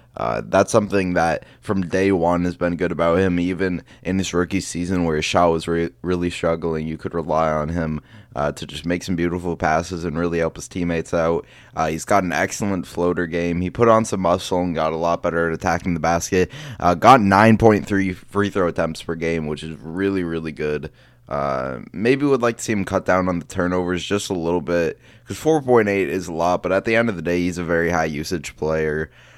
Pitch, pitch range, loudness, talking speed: 90 Hz, 85-95 Hz, -20 LUFS, 225 wpm